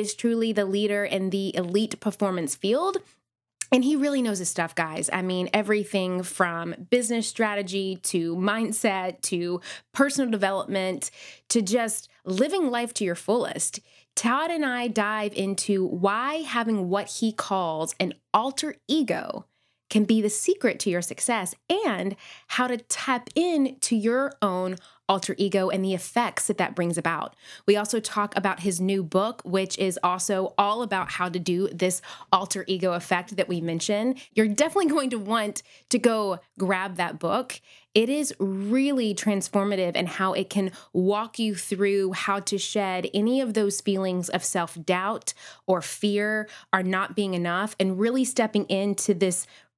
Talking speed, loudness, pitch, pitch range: 160 wpm, -26 LUFS, 200 Hz, 185-225 Hz